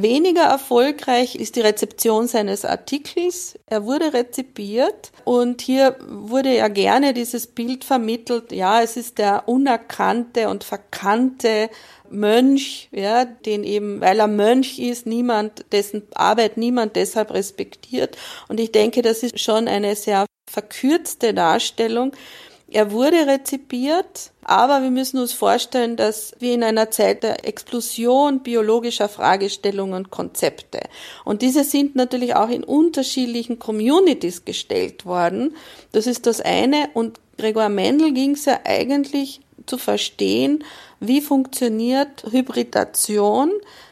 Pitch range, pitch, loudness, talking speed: 220-270 Hz, 240 Hz, -19 LUFS, 130 wpm